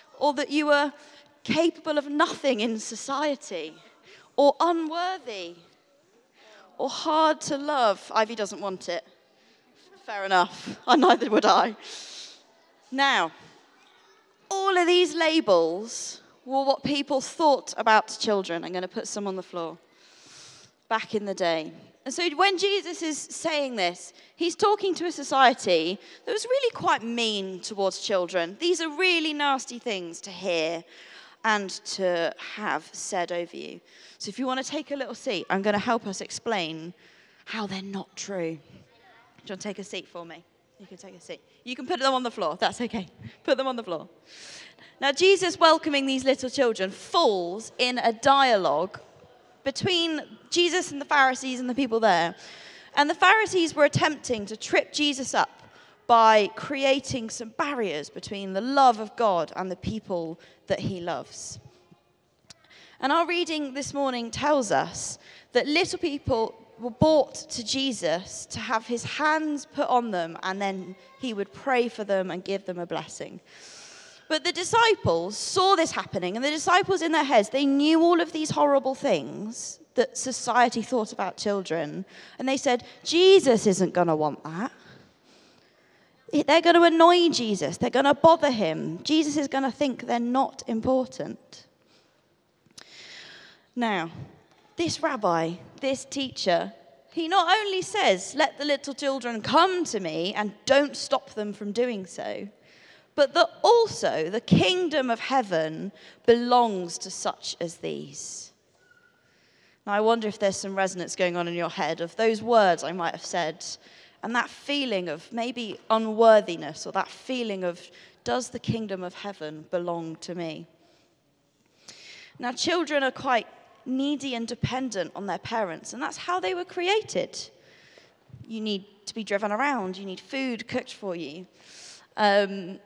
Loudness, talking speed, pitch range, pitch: -25 LUFS, 160 wpm, 195-295 Hz, 245 Hz